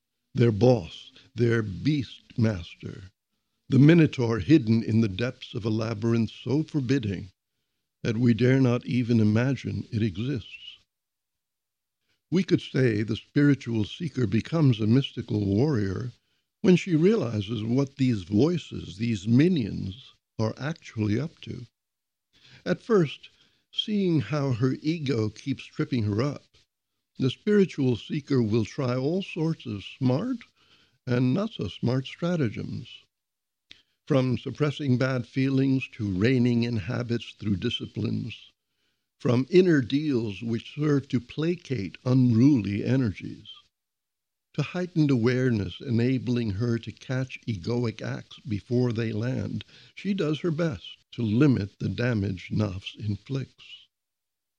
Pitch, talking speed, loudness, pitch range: 120 Hz, 120 wpm, -26 LUFS, 110-140 Hz